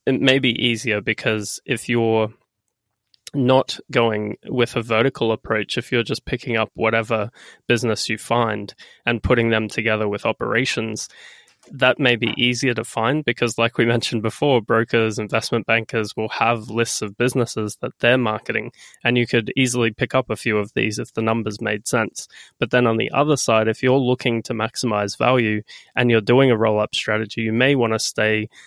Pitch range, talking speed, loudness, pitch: 110-125 Hz, 185 wpm, -20 LUFS, 115 Hz